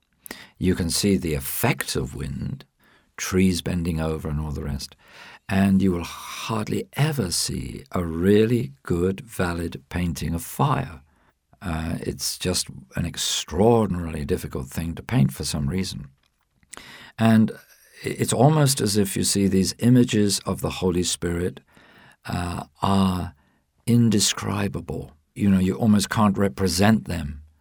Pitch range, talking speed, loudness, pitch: 80-100 Hz, 135 wpm, -23 LUFS, 90 Hz